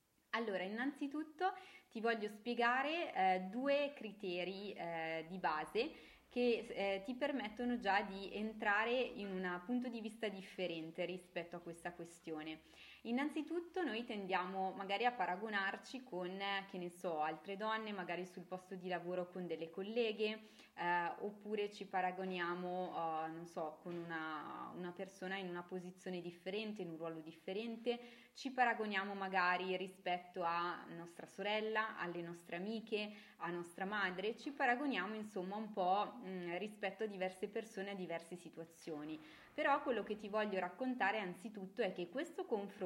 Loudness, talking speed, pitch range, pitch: -42 LUFS, 145 wpm, 180-225 Hz, 195 Hz